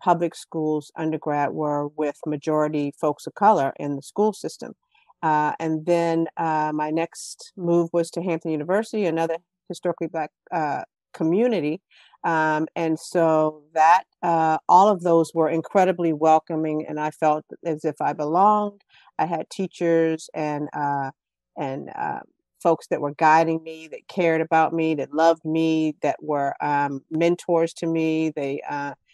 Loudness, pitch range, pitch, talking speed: -23 LUFS, 150-170 Hz, 160 Hz, 150 wpm